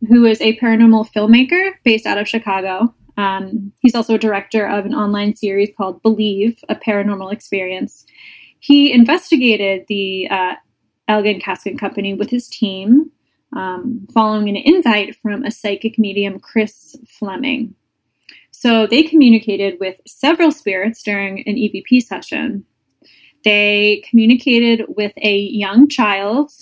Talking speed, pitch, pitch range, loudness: 135 wpm, 215 Hz, 200-235 Hz, -15 LUFS